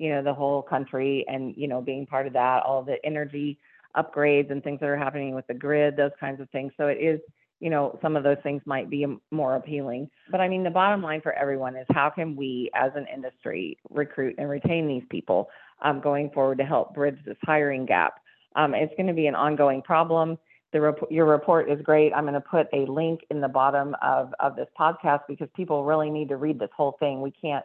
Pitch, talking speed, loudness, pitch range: 145 Hz, 235 wpm, -26 LUFS, 135-155 Hz